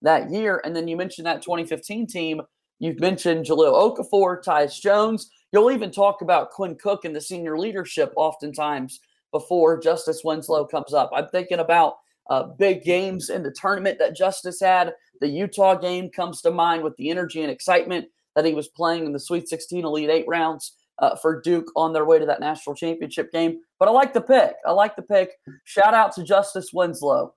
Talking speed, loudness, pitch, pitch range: 195 wpm, -22 LUFS, 170 Hz, 160-190 Hz